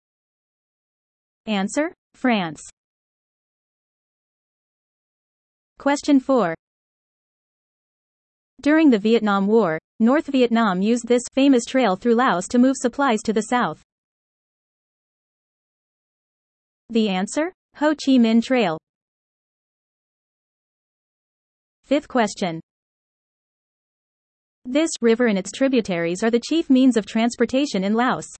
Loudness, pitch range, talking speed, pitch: -20 LUFS, 215-265 Hz, 90 wpm, 240 Hz